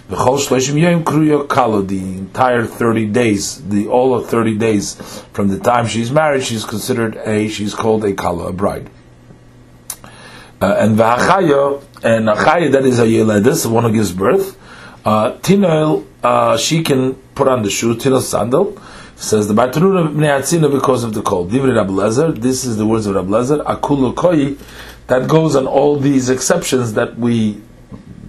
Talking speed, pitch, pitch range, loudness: 155 wpm, 115 Hz, 105-140 Hz, -14 LUFS